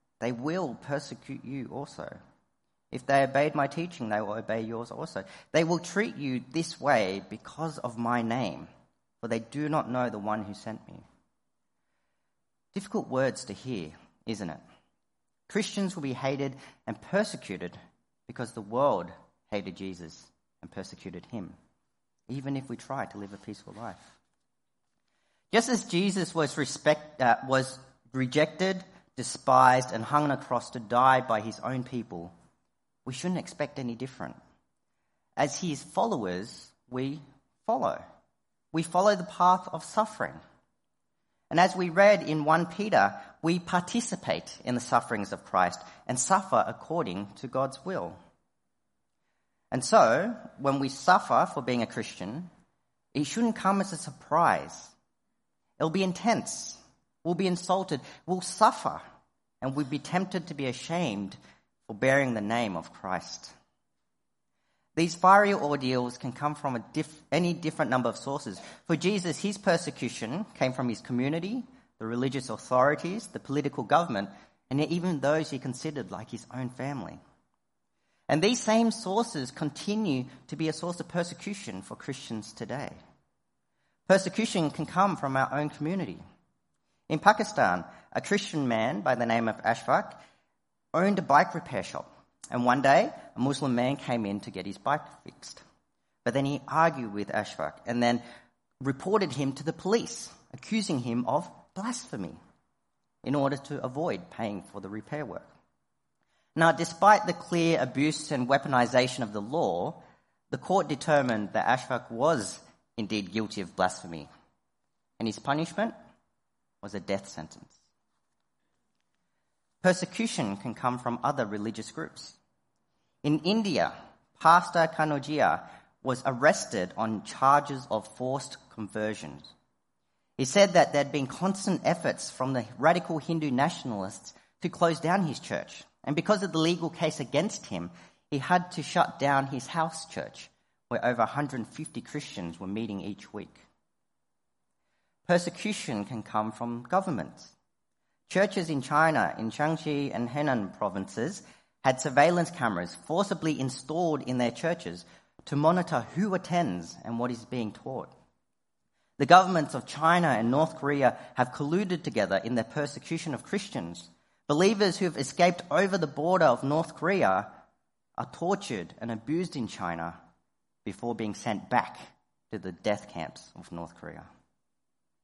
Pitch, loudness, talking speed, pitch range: 140 Hz, -29 LUFS, 145 wpm, 115-170 Hz